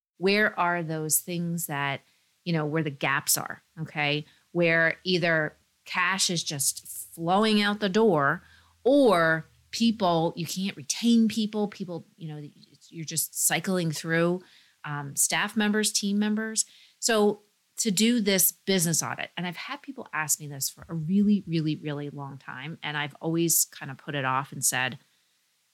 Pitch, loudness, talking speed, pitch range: 165 Hz, -26 LUFS, 160 wpm, 150-205 Hz